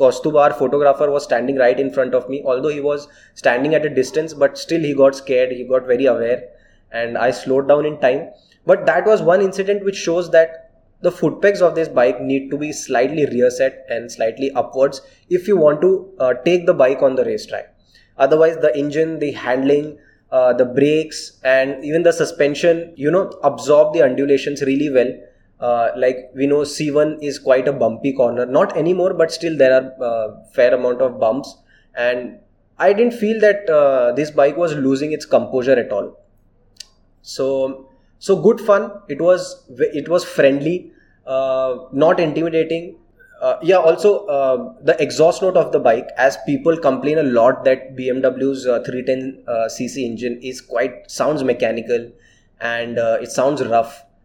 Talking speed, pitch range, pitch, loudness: 180 wpm, 130-165 Hz, 140 Hz, -17 LUFS